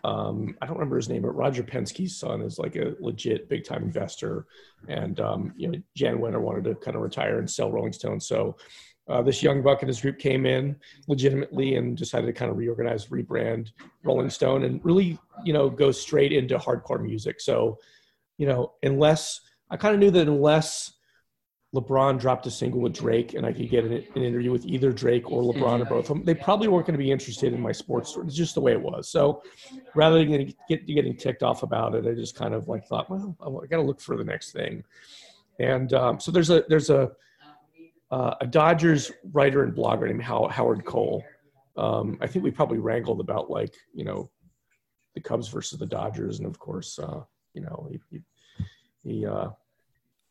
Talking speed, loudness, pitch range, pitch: 210 wpm, -25 LUFS, 125-160 Hz, 140 Hz